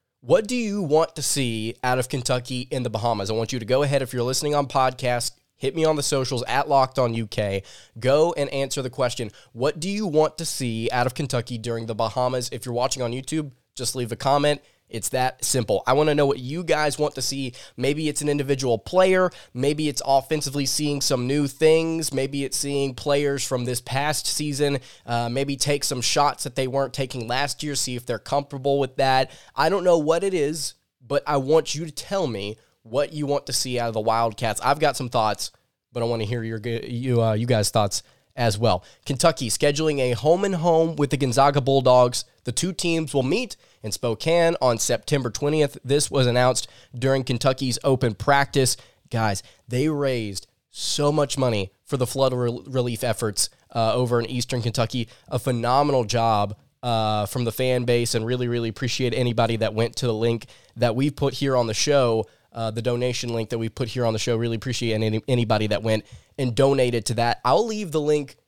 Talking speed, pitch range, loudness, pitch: 210 wpm, 120-145 Hz, -23 LUFS, 130 Hz